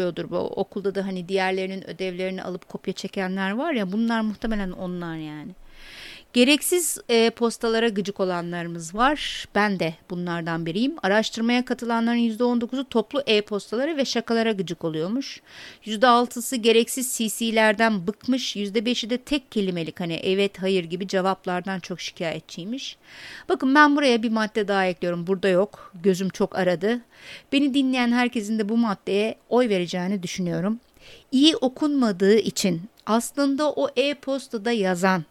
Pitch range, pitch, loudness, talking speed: 190-245 Hz, 215 Hz, -23 LUFS, 130 wpm